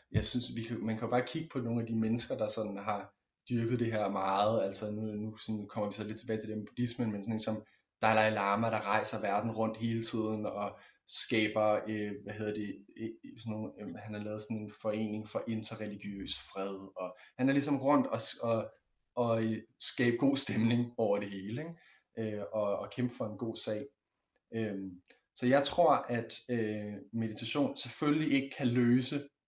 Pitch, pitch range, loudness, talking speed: 110 Hz, 105-120 Hz, -34 LUFS, 195 wpm